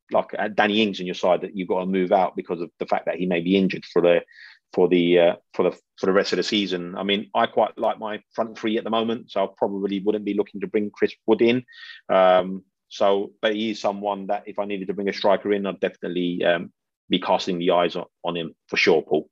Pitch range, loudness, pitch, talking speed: 90-105 Hz, -23 LUFS, 100 Hz, 260 wpm